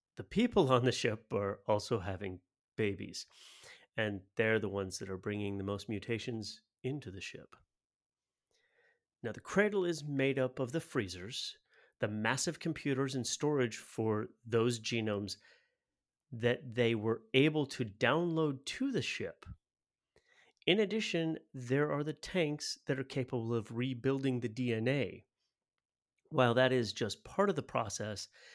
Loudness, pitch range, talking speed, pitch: -35 LUFS, 110-145 Hz, 145 wpm, 125 Hz